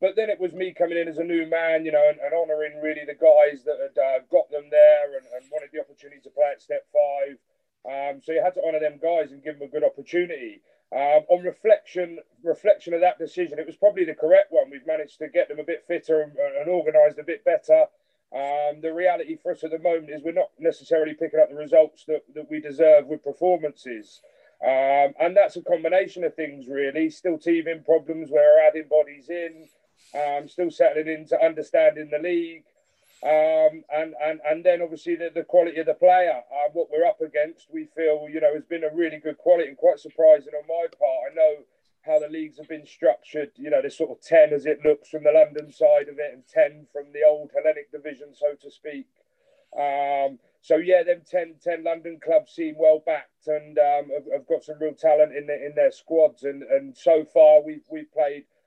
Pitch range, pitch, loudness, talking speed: 150-200 Hz, 160 Hz, -22 LUFS, 225 wpm